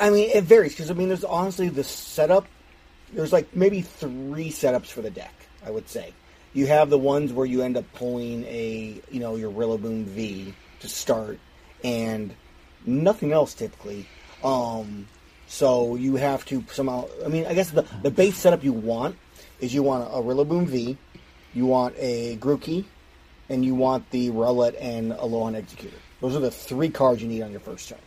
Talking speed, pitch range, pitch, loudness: 195 wpm, 110-145 Hz, 125 Hz, -24 LUFS